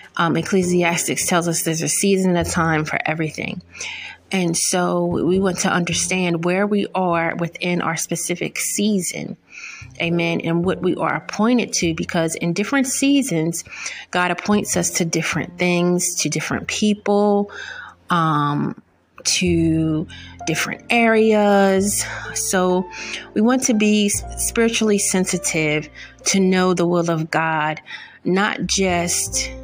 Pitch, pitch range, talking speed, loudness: 180 Hz, 165-205 Hz, 130 wpm, -19 LUFS